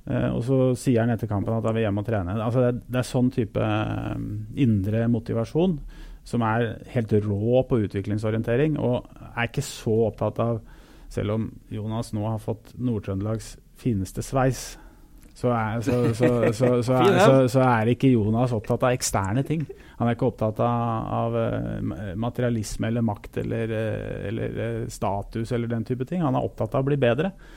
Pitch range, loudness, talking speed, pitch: 110-125 Hz, -25 LUFS, 155 wpm, 115 Hz